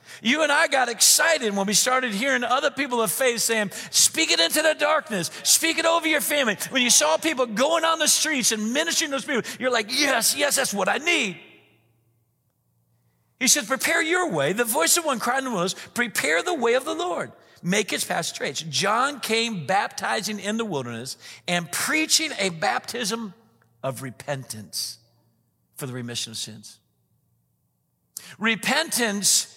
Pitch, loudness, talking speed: 225 Hz, -22 LUFS, 175 wpm